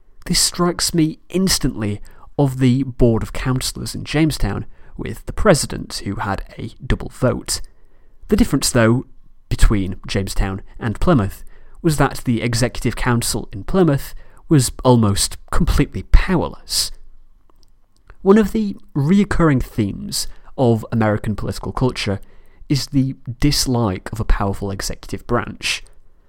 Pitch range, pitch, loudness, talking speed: 100-140 Hz, 115 Hz, -19 LUFS, 125 wpm